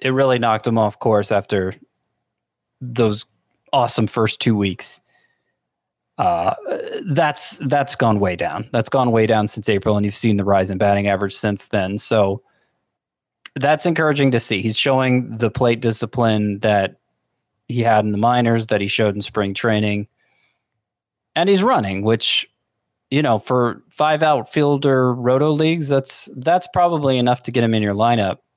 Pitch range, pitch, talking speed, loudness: 105-130 Hz, 115 Hz, 160 wpm, -18 LUFS